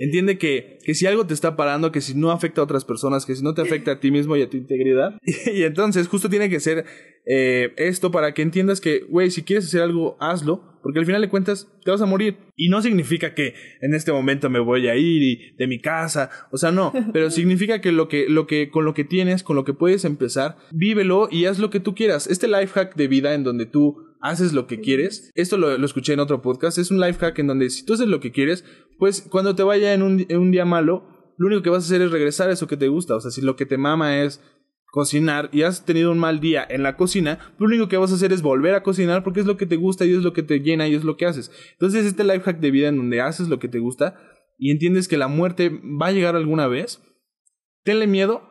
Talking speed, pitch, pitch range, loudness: 270 wpm, 165 Hz, 145-185 Hz, -20 LUFS